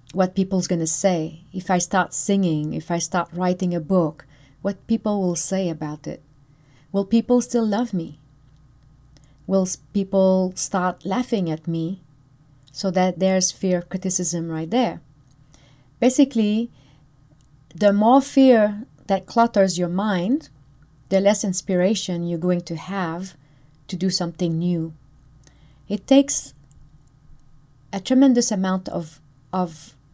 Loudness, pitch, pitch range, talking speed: -21 LUFS, 180 Hz, 150-195 Hz, 130 wpm